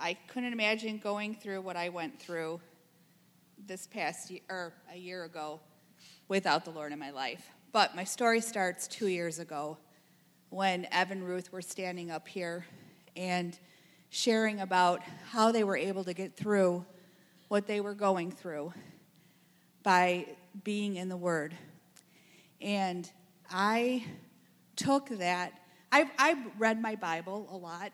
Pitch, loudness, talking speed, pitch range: 180 Hz, -33 LUFS, 145 wpm, 175-200 Hz